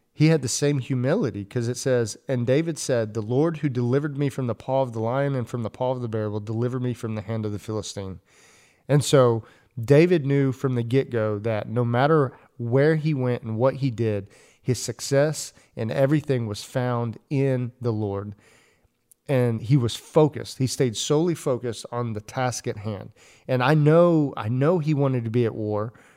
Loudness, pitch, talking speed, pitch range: -24 LUFS, 125 Hz, 200 wpm, 115-140 Hz